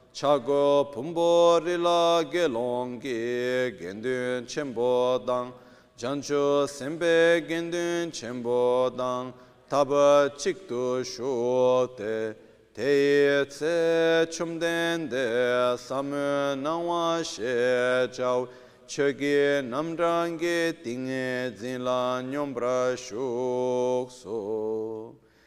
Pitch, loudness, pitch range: 130 Hz, -26 LUFS, 125-160 Hz